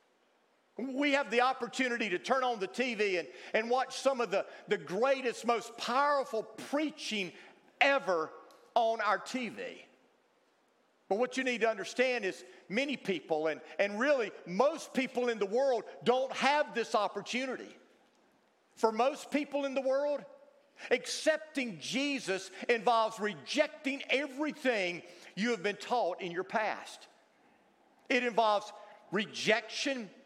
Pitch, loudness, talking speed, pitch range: 240 Hz, -33 LUFS, 130 wpm, 210-270 Hz